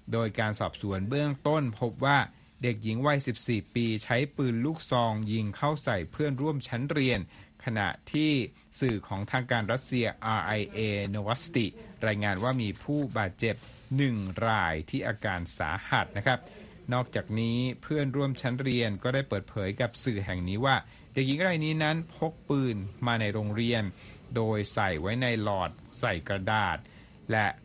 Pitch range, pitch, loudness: 105-135 Hz, 115 Hz, -30 LUFS